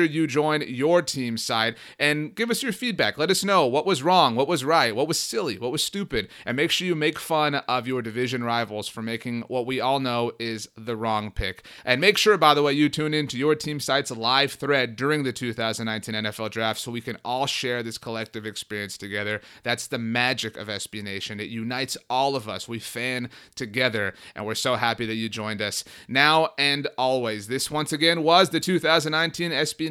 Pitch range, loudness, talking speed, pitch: 115-150 Hz, -24 LUFS, 210 wpm, 125 Hz